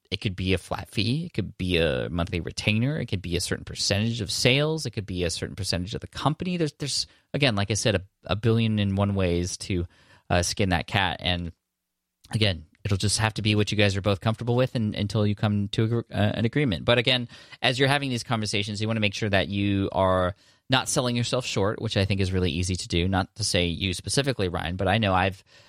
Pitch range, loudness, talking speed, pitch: 95-115 Hz, -25 LUFS, 250 wpm, 105 Hz